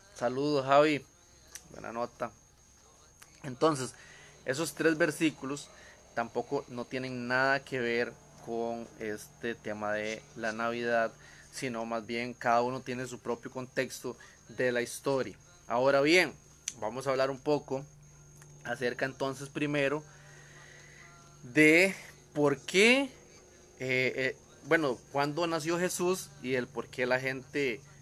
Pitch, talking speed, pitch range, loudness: 130 Hz, 120 wpm, 120-145 Hz, -31 LUFS